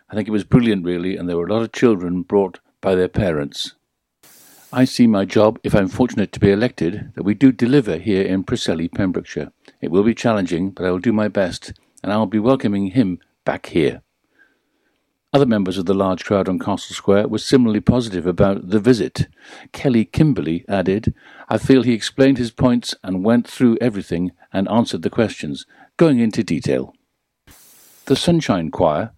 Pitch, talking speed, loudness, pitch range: 105 Hz, 185 wpm, -18 LUFS, 95-125 Hz